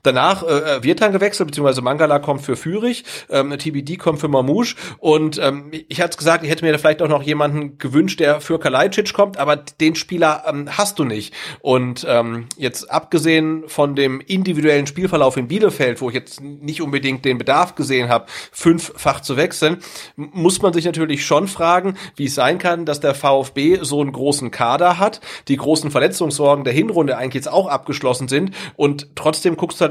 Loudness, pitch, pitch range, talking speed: -17 LUFS, 150 Hz, 140-170 Hz, 195 wpm